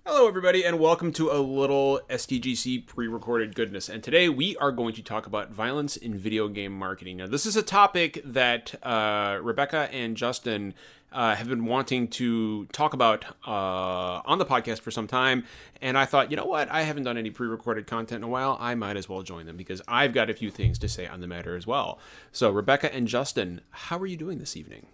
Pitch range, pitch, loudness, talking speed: 105-135 Hz, 120 Hz, -27 LUFS, 225 wpm